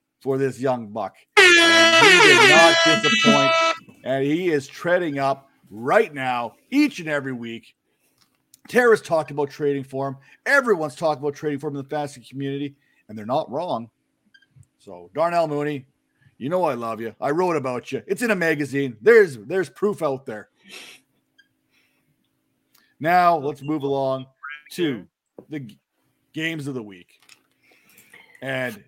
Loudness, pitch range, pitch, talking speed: -19 LUFS, 135-185 Hz, 150 Hz, 150 wpm